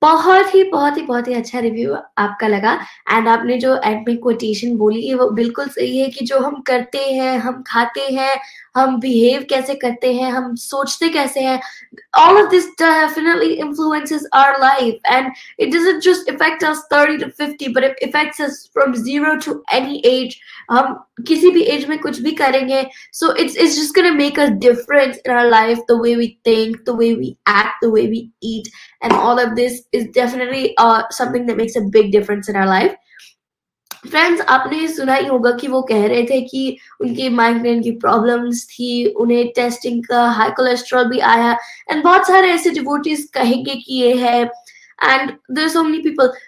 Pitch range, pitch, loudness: 235-290 Hz, 255 Hz, -15 LUFS